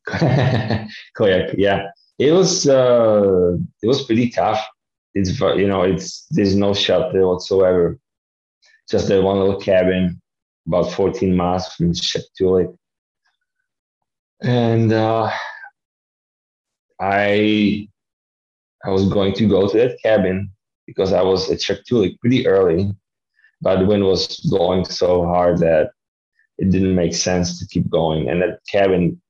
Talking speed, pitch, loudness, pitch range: 130 wpm, 95 Hz, -17 LUFS, 90-110 Hz